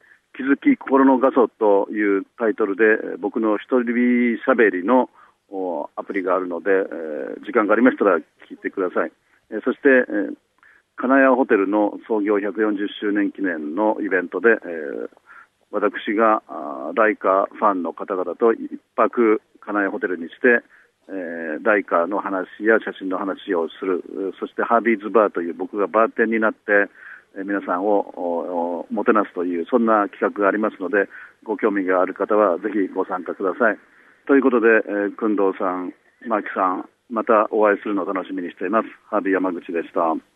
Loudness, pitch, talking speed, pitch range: -20 LUFS, 110 Hz, 310 characters per minute, 100-120 Hz